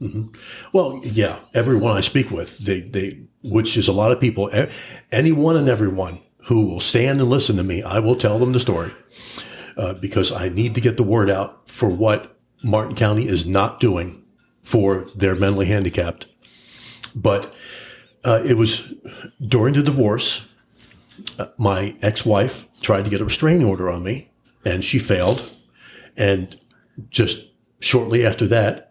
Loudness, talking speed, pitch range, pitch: -19 LUFS, 160 wpm, 100-125 Hz, 110 Hz